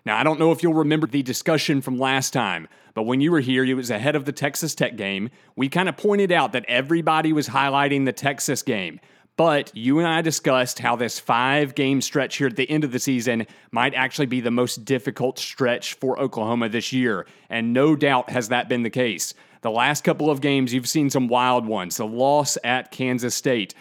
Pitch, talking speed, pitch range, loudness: 135 Hz, 220 wpm, 125-150 Hz, -22 LUFS